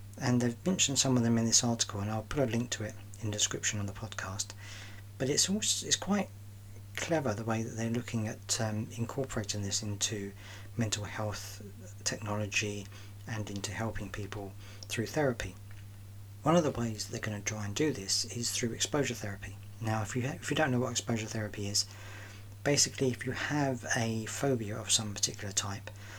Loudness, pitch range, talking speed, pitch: -32 LUFS, 100-120 Hz, 195 wpm, 105 Hz